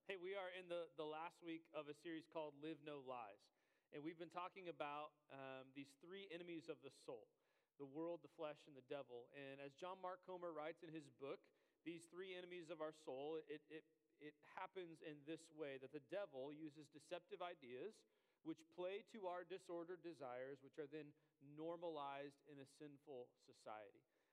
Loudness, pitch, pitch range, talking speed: -56 LUFS, 160 Hz, 145-180 Hz, 185 wpm